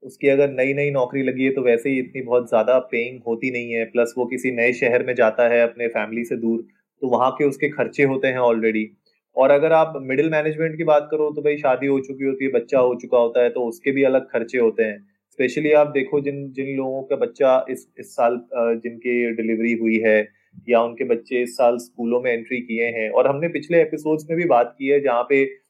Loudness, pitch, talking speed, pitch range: -20 LUFS, 130 Hz, 235 wpm, 120-140 Hz